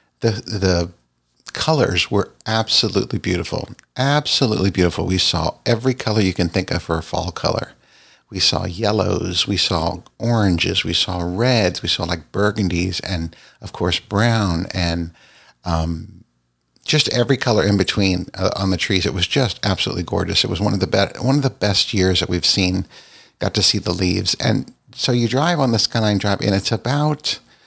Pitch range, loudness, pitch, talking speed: 90-110 Hz, -19 LUFS, 95 Hz, 180 wpm